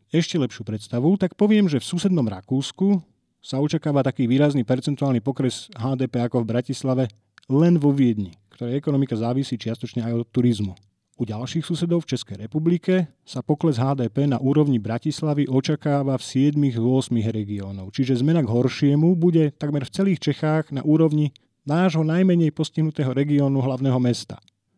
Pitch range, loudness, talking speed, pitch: 120-155 Hz, -22 LUFS, 150 wpm, 135 Hz